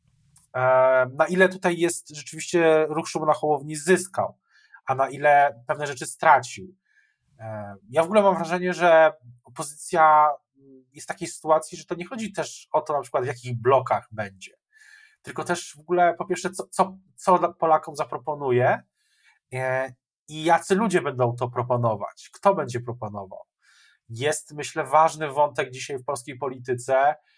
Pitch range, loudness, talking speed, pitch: 130-170 Hz, -23 LUFS, 150 wpm, 150 Hz